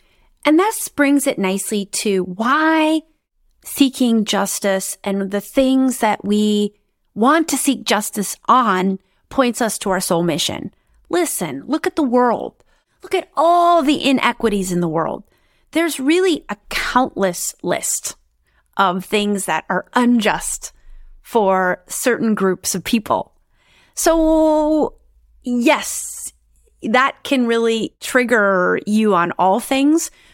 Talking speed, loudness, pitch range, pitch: 125 wpm, -17 LUFS, 200-290 Hz, 235 Hz